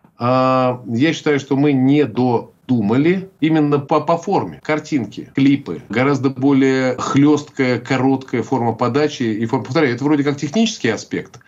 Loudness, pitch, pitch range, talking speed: -17 LUFS, 140 Hz, 130-150 Hz, 135 wpm